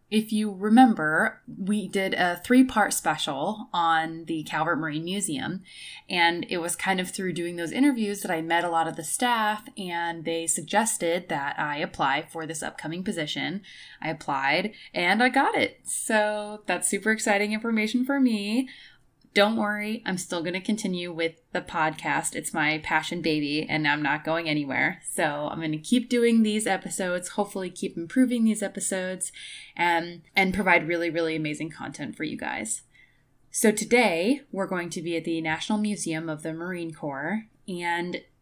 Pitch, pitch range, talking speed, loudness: 180 Hz, 165-210 Hz, 175 wpm, -26 LUFS